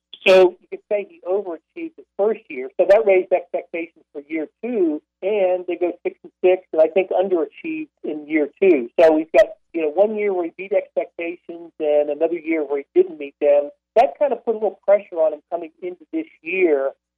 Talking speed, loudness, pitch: 215 wpm, -20 LUFS, 185 Hz